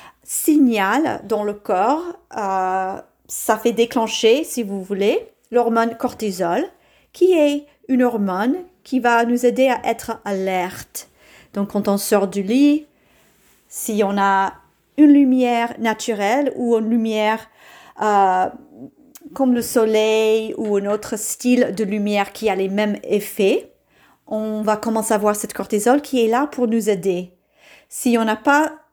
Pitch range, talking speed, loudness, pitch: 210-265 Hz, 145 wpm, -19 LUFS, 225 Hz